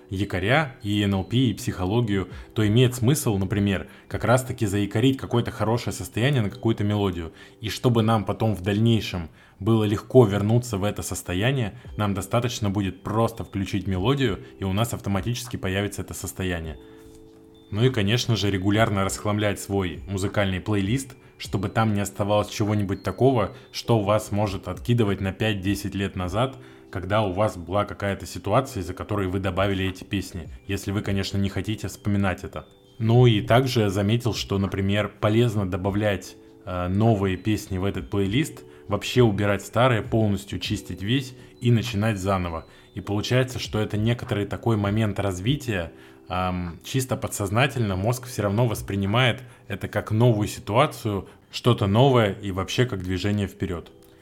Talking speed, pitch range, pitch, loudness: 150 wpm, 95-115 Hz, 105 Hz, -24 LUFS